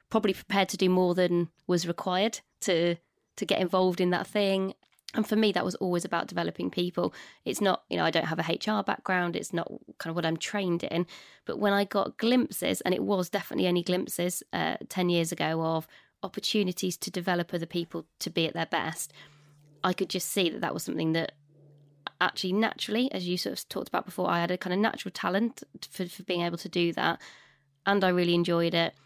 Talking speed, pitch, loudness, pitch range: 215 wpm, 180 Hz, -29 LUFS, 170-200 Hz